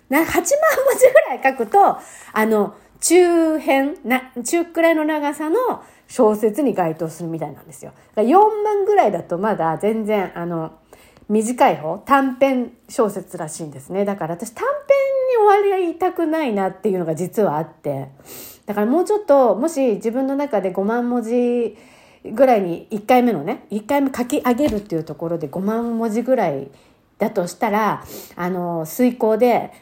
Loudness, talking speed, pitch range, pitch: -19 LUFS, 305 characters per minute, 190-285 Hz, 235 Hz